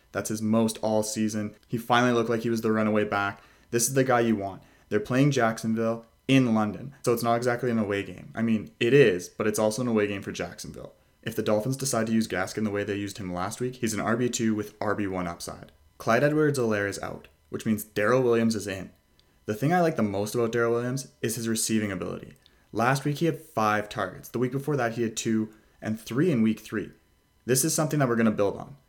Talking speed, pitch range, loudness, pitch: 240 wpm, 105-120 Hz, -26 LUFS, 110 Hz